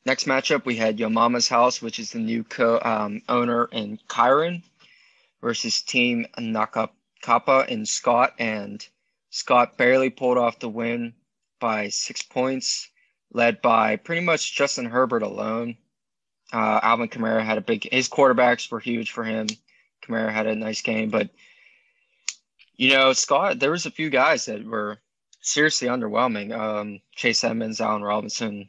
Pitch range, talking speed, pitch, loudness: 110-130 Hz, 155 wpm, 115 Hz, -22 LUFS